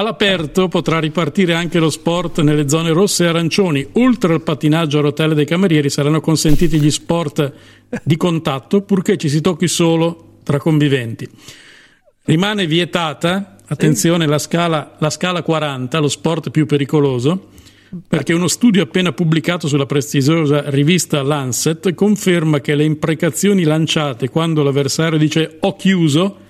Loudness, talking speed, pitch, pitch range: -15 LUFS, 140 wpm, 160 Hz, 150-175 Hz